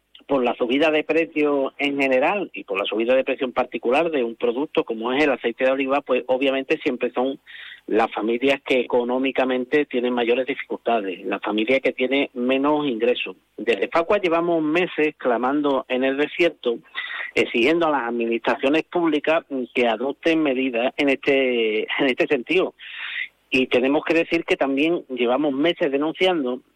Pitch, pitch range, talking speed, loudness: 140 Hz, 125-160 Hz, 160 wpm, -21 LUFS